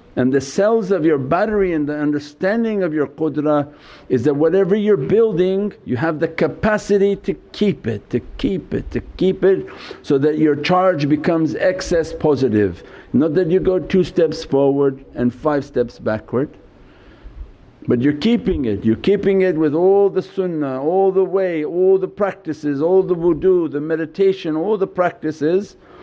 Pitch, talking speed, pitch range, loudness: 165 Hz, 170 wpm, 145-190 Hz, -18 LUFS